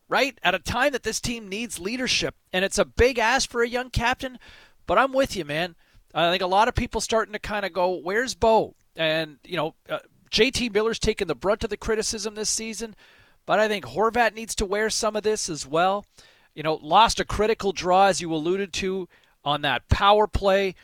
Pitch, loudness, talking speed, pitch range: 210 Hz, -24 LUFS, 220 wpm, 180-225 Hz